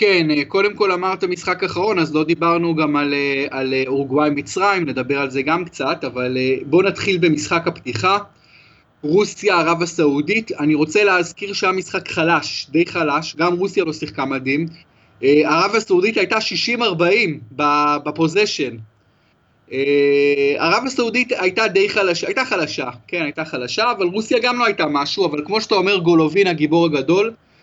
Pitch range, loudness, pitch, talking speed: 145-195 Hz, -18 LUFS, 165 Hz, 150 wpm